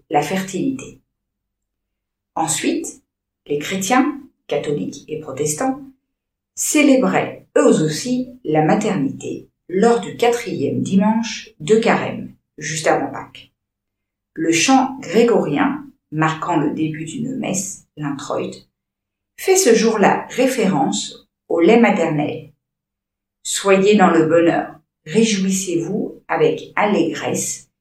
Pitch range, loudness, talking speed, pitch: 160-255 Hz, -18 LUFS, 95 wpm, 210 Hz